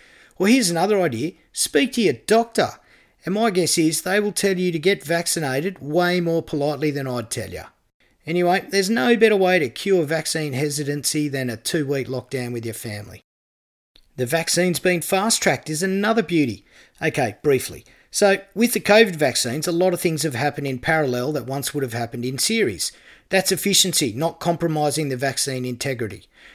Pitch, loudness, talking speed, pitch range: 160 Hz, -21 LUFS, 180 wpm, 135-190 Hz